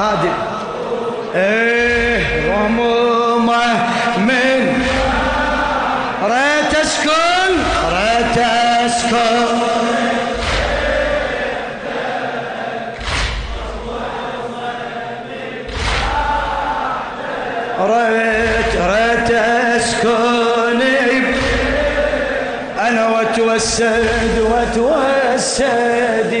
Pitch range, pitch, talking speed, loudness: 235-260 Hz, 235 Hz, 30 wpm, -15 LUFS